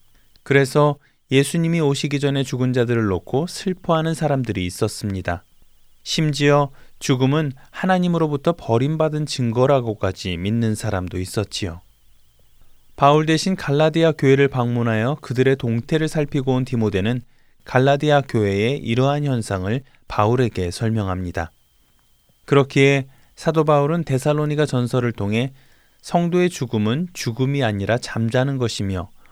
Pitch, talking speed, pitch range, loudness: 130 Hz, 310 characters per minute, 110-145 Hz, -20 LUFS